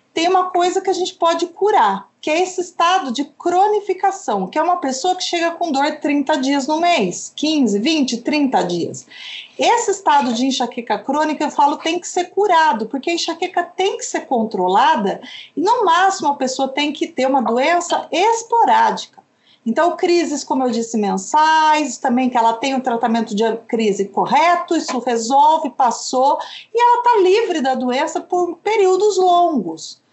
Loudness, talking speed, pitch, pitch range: -17 LUFS, 175 wpm, 310 Hz, 265-360 Hz